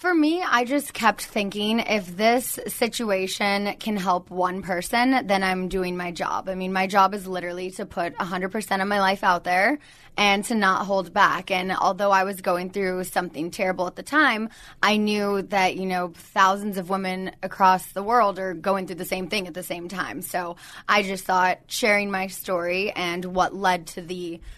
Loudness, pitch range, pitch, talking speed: -23 LUFS, 180-205 Hz, 190 Hz, 200 wpm